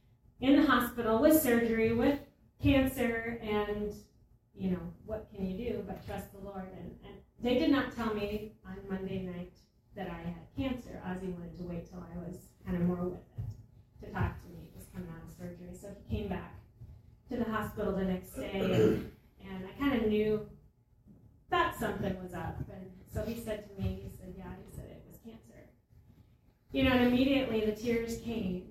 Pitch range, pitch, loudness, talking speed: 170-230 Hz, 195 Hz, -33 LUFS, 200 wpm